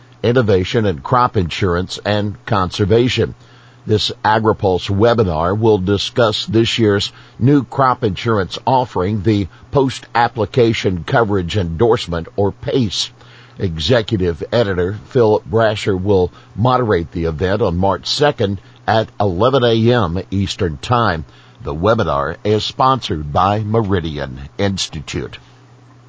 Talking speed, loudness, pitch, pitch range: 110 wpm, -16 LUFS, 105 Hz, 95-120 Hz